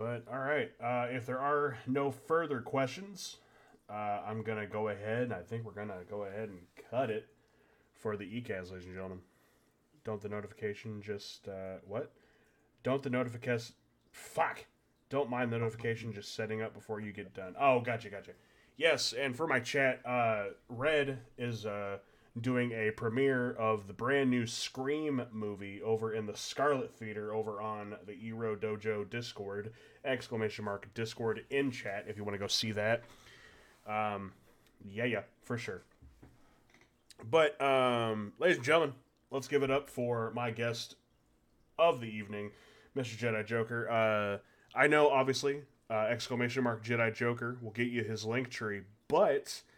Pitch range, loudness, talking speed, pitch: 105-125 Hz, -35 LUFS, 165 wpm, 115 Hz